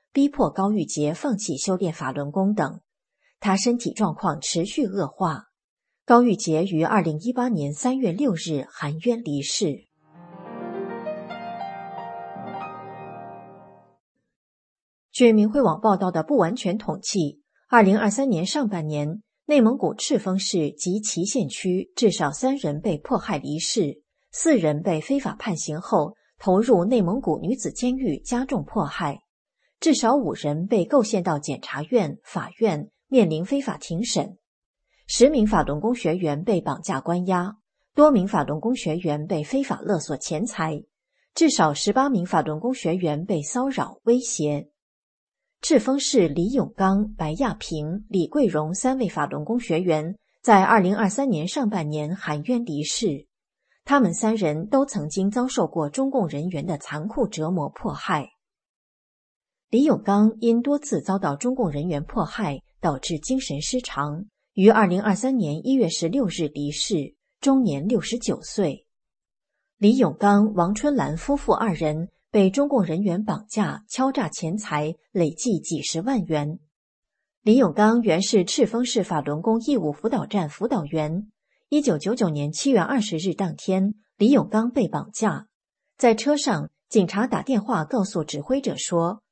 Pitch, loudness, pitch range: 195 Hz, -23 LUFS, 155-240 Hz